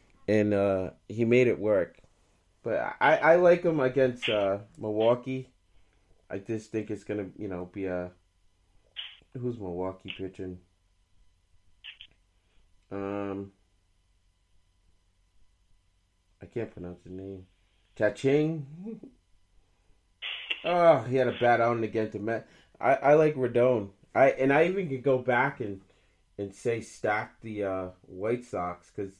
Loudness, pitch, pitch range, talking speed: -28 LUFS, 100 Hz, 90-120 Hz, 125 wpm